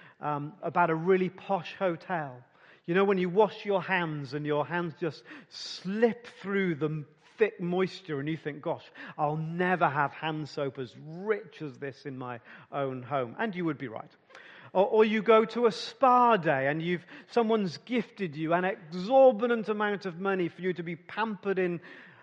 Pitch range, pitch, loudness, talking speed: 150-200 Hz, 175 Hz, -29 LUFS, 185 wpm